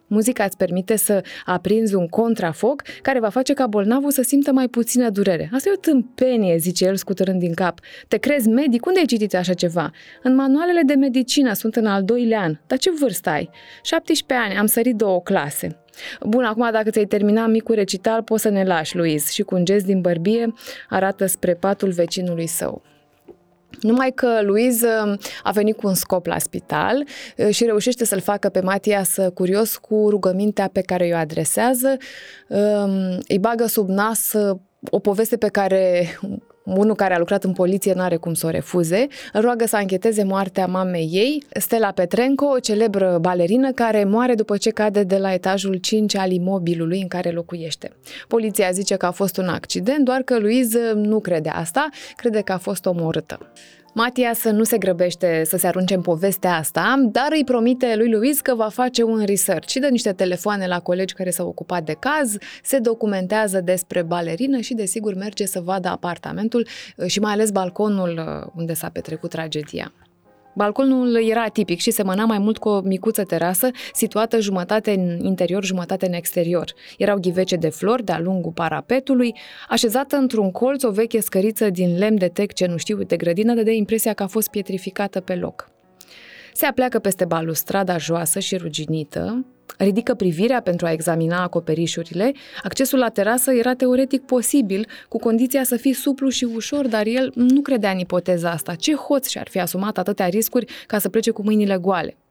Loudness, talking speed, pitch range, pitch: -20 LUFS, 180 wpm, 185-235 Hz, 205 Hz